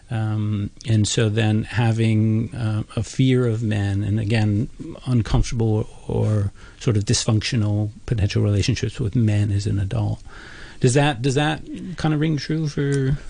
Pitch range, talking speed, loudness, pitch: 105-130 Hz, 155 wpm, -21 LUFS, 115 Hz